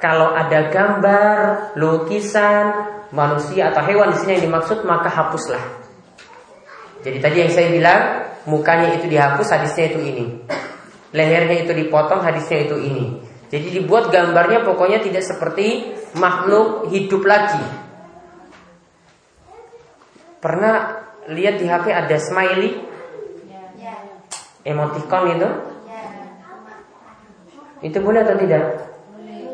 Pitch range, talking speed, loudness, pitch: 160-210 Hz, 105 wpm, -17 LUFS, 185 Hz